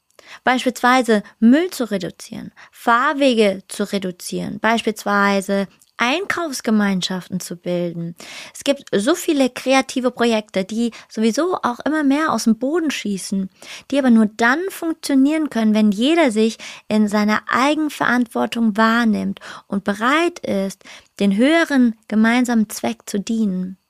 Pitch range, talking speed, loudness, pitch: 205-265 Hz, 120 wpm, -18 LUFS, 225 Hz